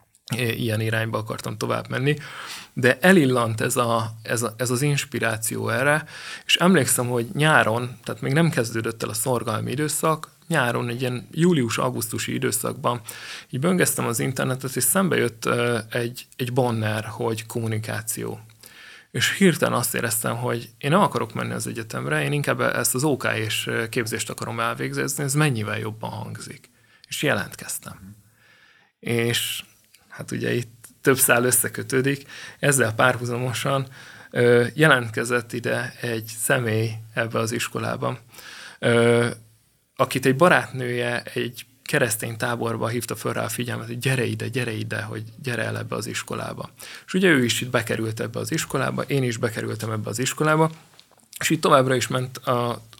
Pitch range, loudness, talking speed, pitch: 115-135 Hz, -23 LUFS, 150 wpm, 120 Hz